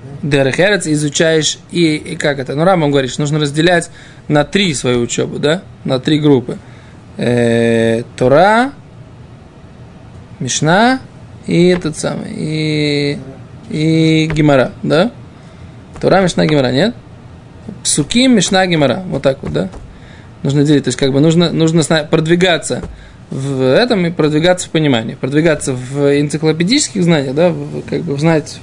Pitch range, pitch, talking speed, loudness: 140-170 Hz, 150 Hz, 130 wpm, -13 LUFS